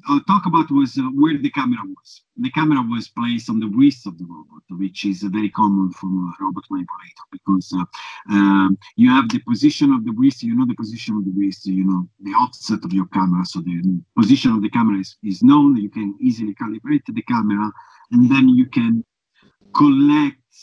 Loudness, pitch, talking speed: -18 LUFS, 140 Hz, 210 wpm